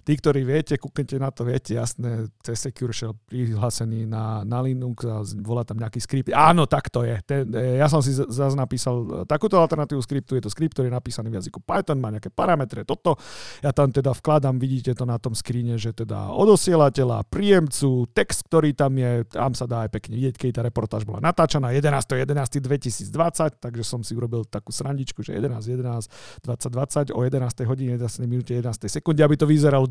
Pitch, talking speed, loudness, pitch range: 125 Hz, 175 wpm, -23 LUFS, 115-140 Hz